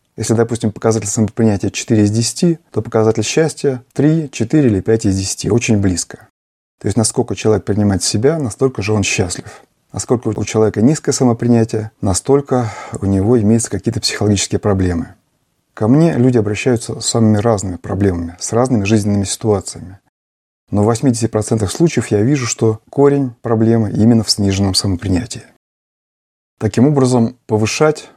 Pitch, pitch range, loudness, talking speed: 110 Hz, 105-125 Hz, -15 LUFS, 145 wpm